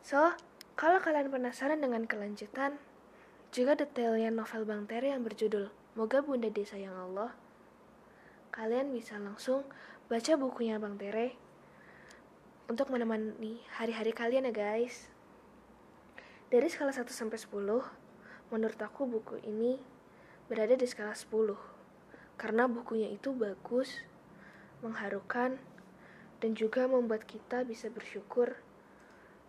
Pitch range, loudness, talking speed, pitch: 215-255 Hz, -35 LUFS, 110 wpm, 230 Hz